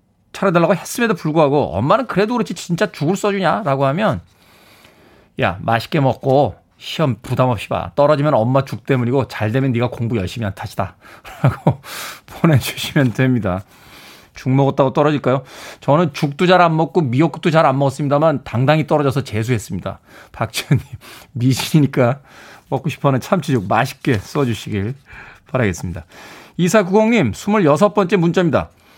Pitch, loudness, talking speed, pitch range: 140 Hz, -17 LUFS, 345 characters per minute, 125-165 Hz